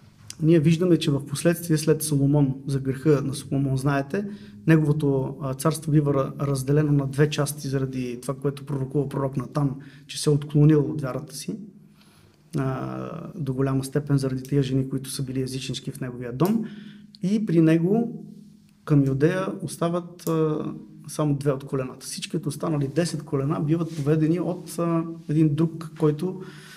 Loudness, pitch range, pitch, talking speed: -24 LUFS, 135-165 Hz, 150 Hz, 145 wpm